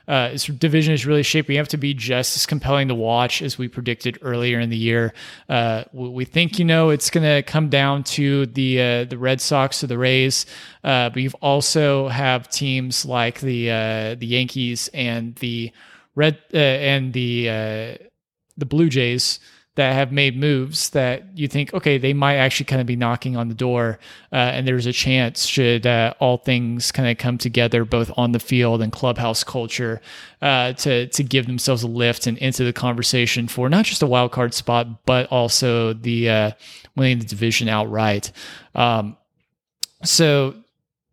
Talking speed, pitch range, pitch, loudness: 185 wpm, 120-140 Hz, 125 Hz, -19 LUFS